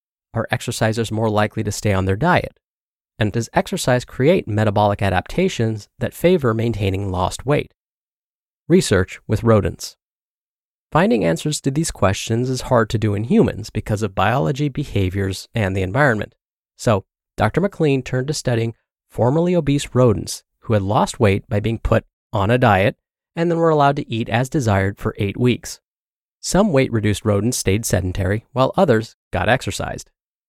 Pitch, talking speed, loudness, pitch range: 115 Hz, 160 wpm, -19 LUFS, 100-130 Hz